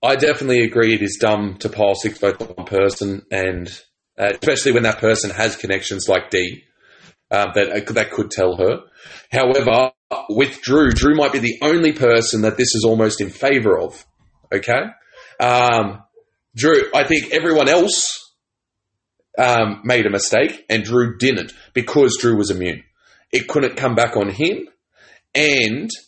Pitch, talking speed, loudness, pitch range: 115 Hz, 165 wpm, -17 LUFS, 100-130 Hz